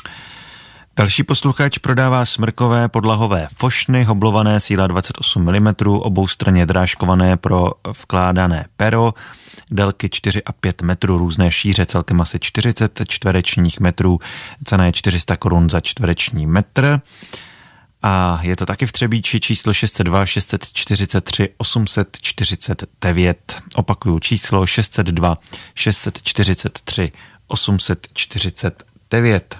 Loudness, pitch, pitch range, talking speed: -16 LUFS, 100 Hz, 90-115 Hz, 100 wpm